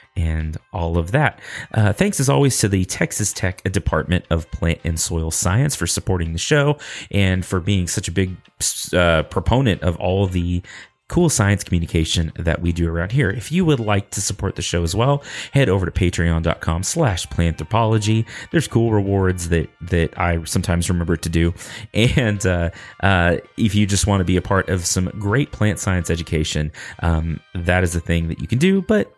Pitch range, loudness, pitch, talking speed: 85-105 Hz, -19 LUFS, 95 Hz, 195 wpm